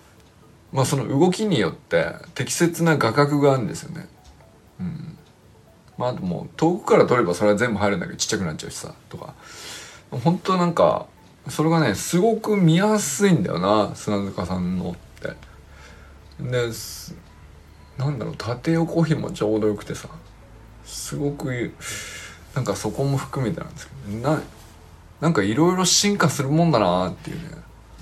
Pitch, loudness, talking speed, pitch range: 135 Hz, -22 LUFS, 310 characters per minute, 100-165 Hz